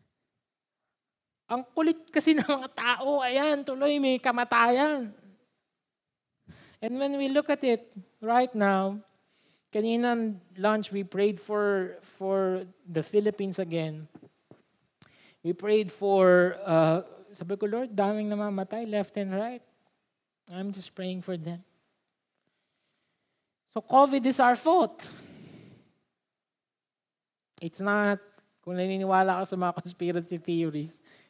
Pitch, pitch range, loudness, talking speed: 205 Hz, 185-245 Hz, -27 LUFS, 110 wpm